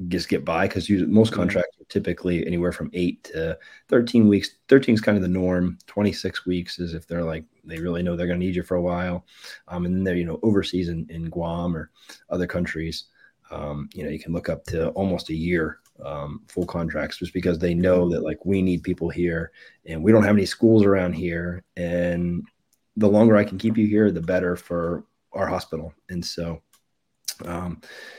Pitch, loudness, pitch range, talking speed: 90 Hz, -23 LUFS, 85-95 Hz, 210 wpm